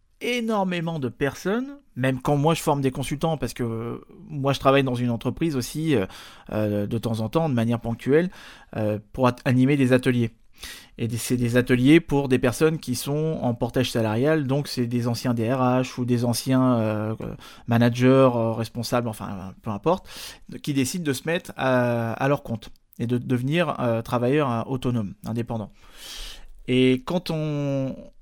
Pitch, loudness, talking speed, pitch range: 125 Hz, -24 LUFS, 170 wpm, 115-145 Hz